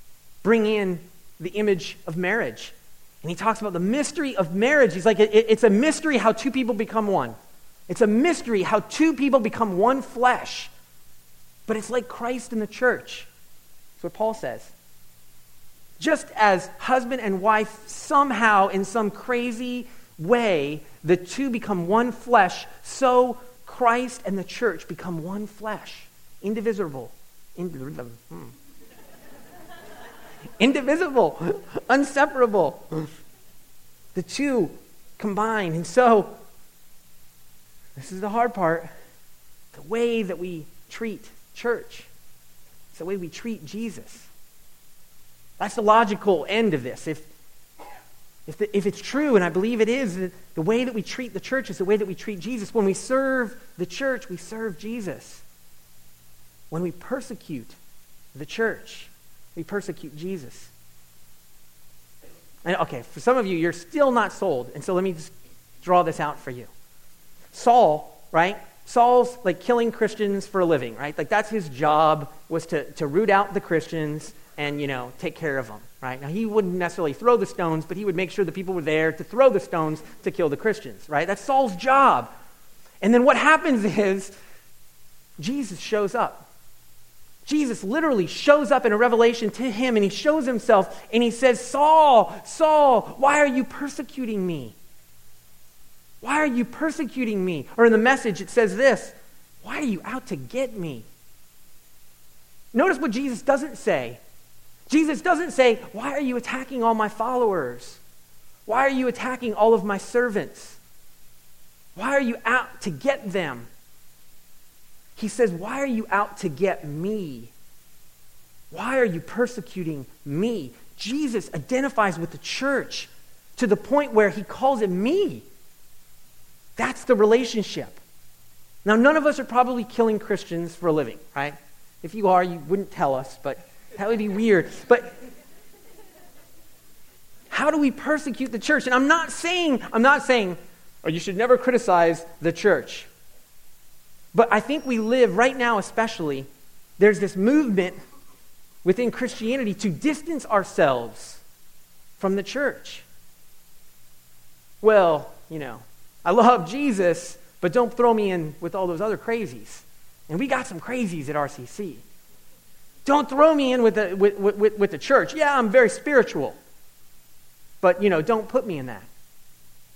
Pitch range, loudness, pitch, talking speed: 165-245 Hz, -23 LUFS, 205 Hz, 155 wpm